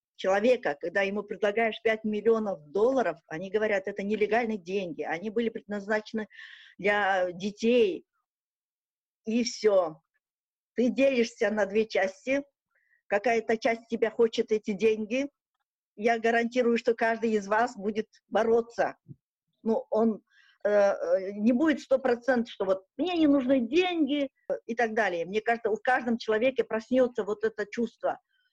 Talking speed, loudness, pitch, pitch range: 135 wpm, -28 LUFS, 225 Hz, 205-245 Hz